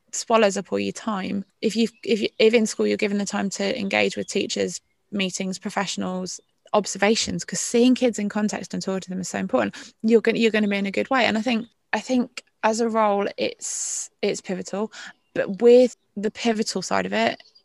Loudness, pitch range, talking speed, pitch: -23 LUFS, 195-230 Hz, 215 wpm, 210 Hz